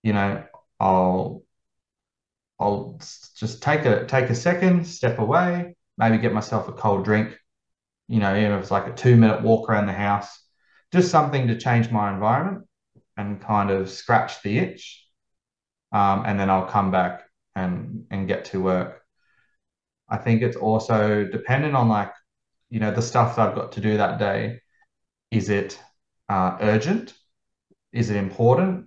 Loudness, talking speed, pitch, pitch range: -22 LUFS, 165 wpm, 110 Hz, 100-120 Hz